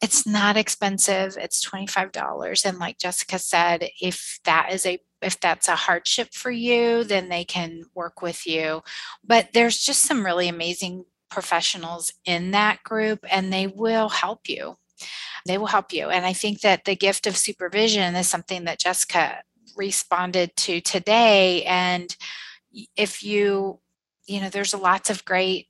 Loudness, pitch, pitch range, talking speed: -22 LUFS, 195 Hz, 180-210 Hz, 165 wpm